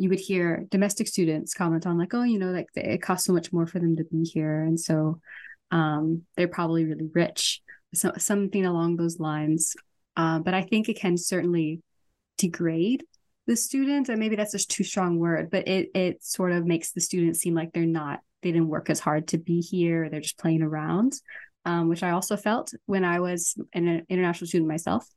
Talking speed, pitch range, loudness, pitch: 210 wpm, 165-190 Hz, -26 LUFS, 175 Hz